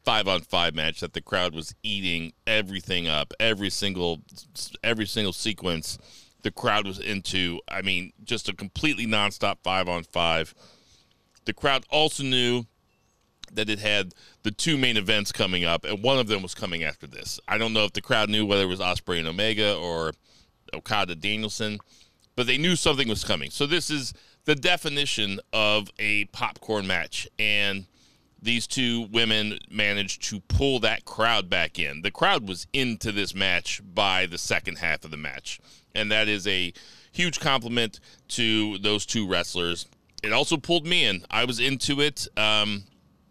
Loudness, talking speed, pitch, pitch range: -25 LUFS, 175 wpm, 105 Hz, 90-115 Hz